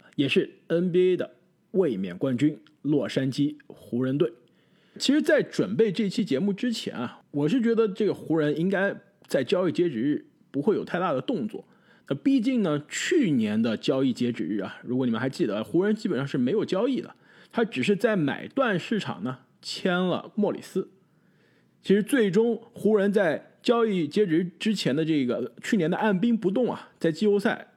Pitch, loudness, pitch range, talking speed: 195 Hz, -26 LUFS, 160-225 Hz, 270 characters per minute